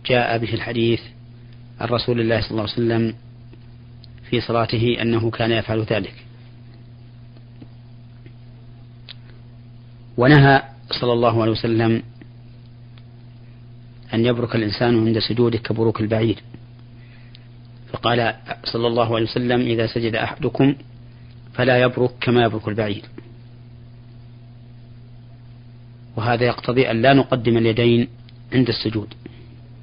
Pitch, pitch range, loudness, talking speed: 120 Hz, 115-120 Hz, -19 LUFS, 100 wpm